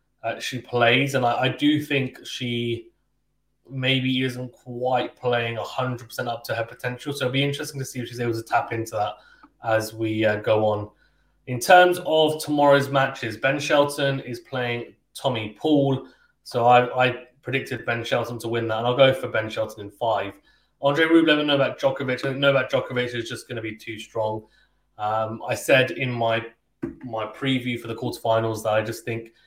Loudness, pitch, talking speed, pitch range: -23 LUFS, 125 Hz, 200 wpm, 115-135 Hz